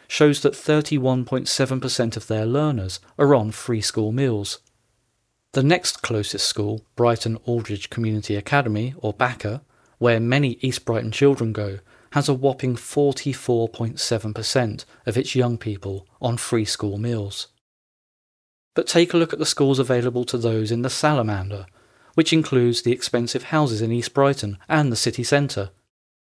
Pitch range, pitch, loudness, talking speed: 110-135 Hz, 120 Hz, -22 LUFS, 145 wpm